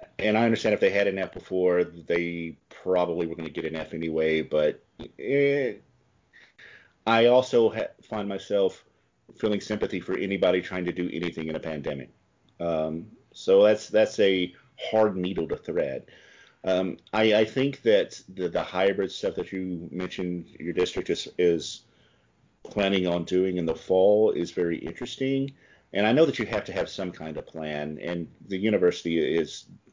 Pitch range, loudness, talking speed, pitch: 85-110 Hz, -26 LUFS, 170 wpm, 90 Hz